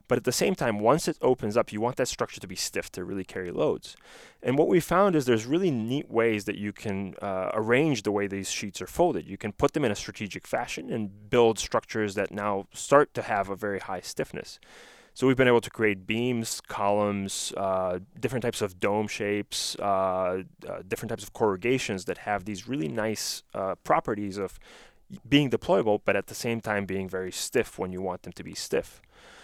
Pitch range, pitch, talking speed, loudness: 95-115 Hz, 105 Hz, 215 wpm, -28 LUFS